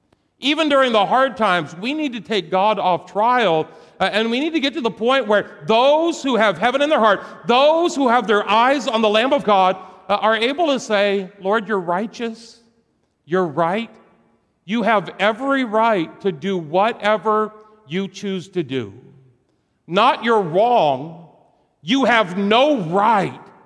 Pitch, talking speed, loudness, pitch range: 215 Hz, 170 wpm, -18 LUFS, 190-245 Hz